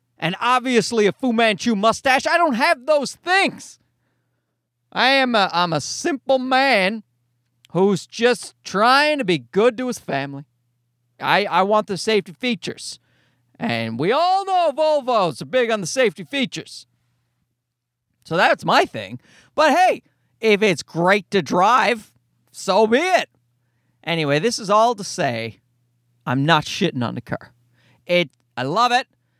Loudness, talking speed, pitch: -19 LUFS, 150 wpm, 190 Hz